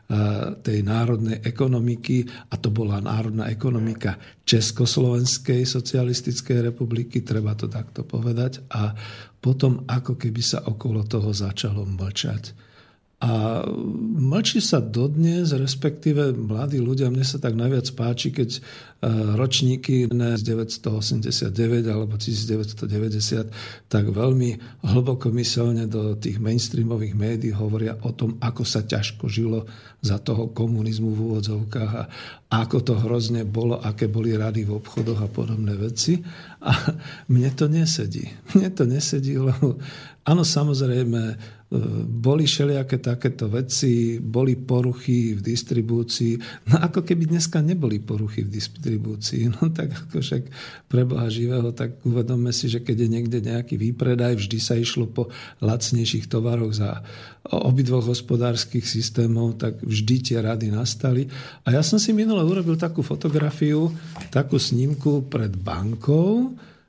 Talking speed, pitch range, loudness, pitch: 130 wpm, 110-135 Hz, -23 LUFS, 120 Hz